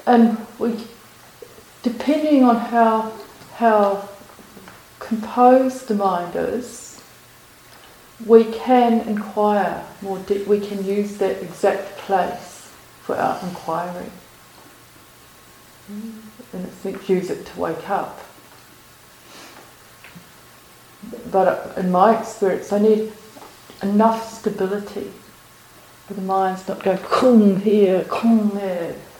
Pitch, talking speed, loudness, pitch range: 205 Hz, 100 wpm, -19 LUFS, 190-225 Hz